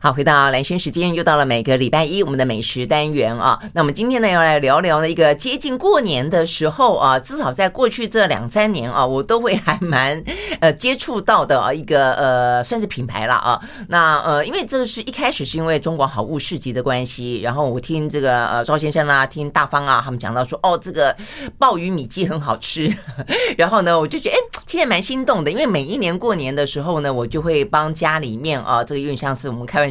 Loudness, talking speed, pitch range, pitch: -18 LUFS, 340 characters per minute, 130-180 Hz, 150 Hz